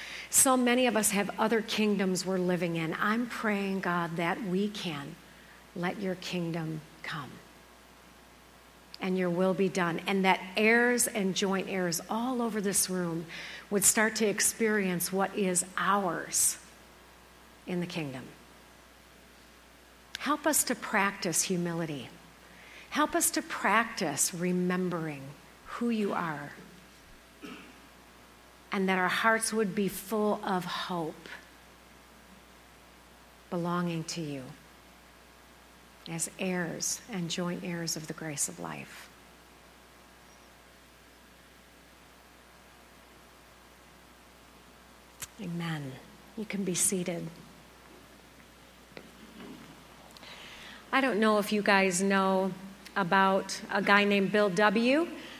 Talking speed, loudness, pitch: 105 wpm, -29 LUFS, 175 Hz